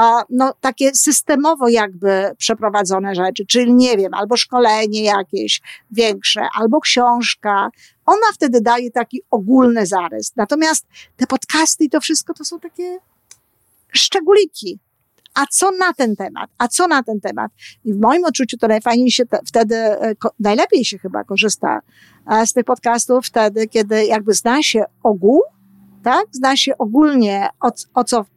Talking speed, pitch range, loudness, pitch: 150 wpm, 215-275 Hz, -15 LUFS, 240 Hz